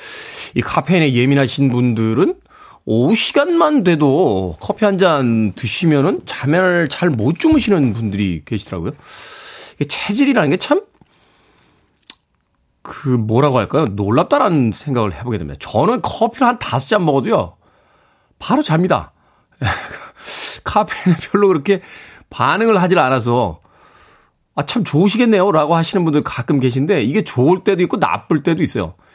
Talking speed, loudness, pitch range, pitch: 290 characters per minute, -16 LUFS, 125-205 Hz, 160 Hz